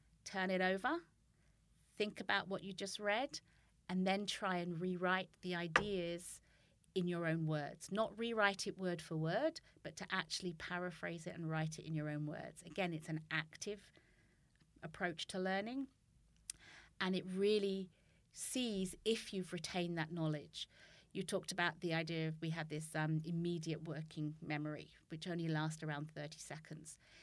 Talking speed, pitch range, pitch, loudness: 160 wpm, 160-190 Hz, 175 Hz, -41 LUFS